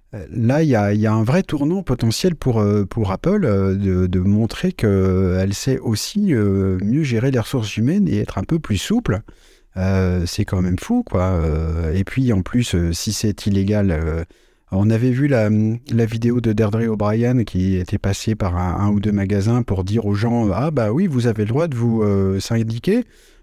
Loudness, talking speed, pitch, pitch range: -19 LUFS, 190 wpm, 105 Hz, 95-120 Hz